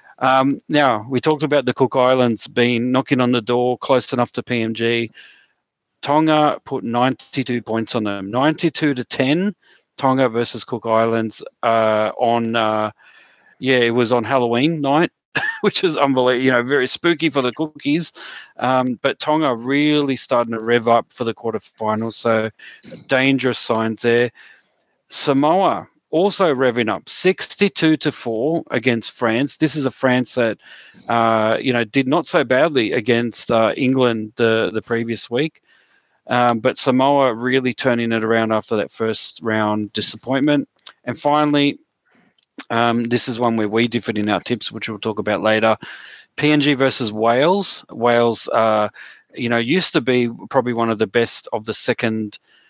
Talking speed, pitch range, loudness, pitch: 160 wpm, 115-135 Hz, -18 LUFS, 125 Hz